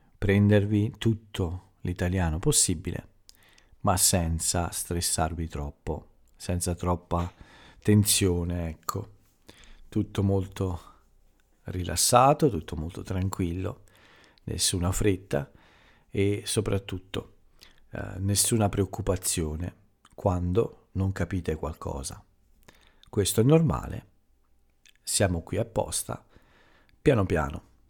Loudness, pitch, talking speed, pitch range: -27 LUFS, 95 Hz, 80 wpm, 85-100 Hz